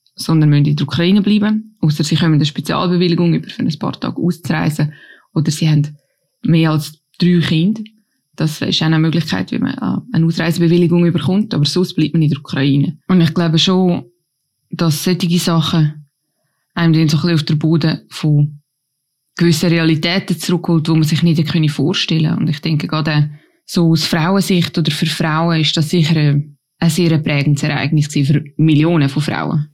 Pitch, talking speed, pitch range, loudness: 160 Hz, 170 wpm, 150-170 Hz, -15 LUFS